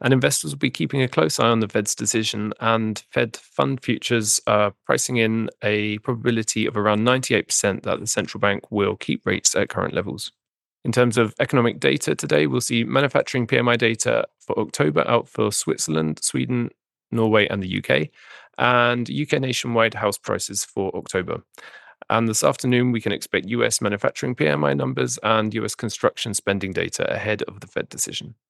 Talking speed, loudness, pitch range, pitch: 175 wpm, -21 LUFS, 105-125 Hz, 115 Hz